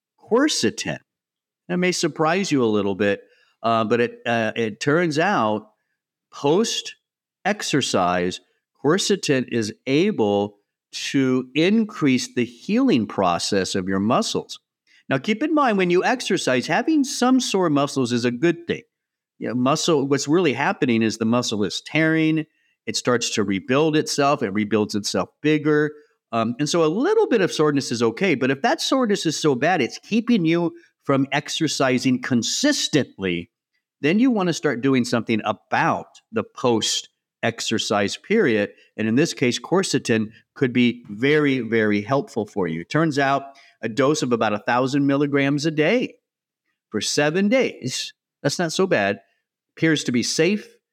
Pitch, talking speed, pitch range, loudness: 140 Hz, 150 wpm, 115-175 Hz, -21 LUFS